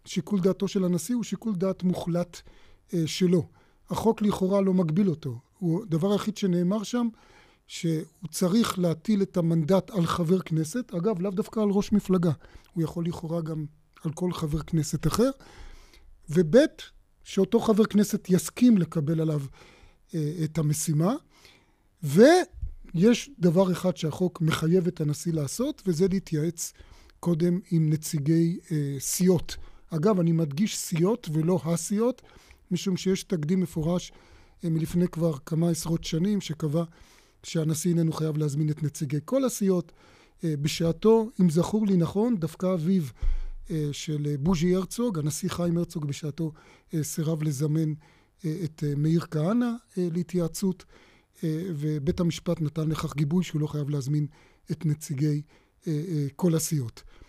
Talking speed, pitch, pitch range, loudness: 130 wpm, 170 Hz, 155-190 Hz, -27 LUFS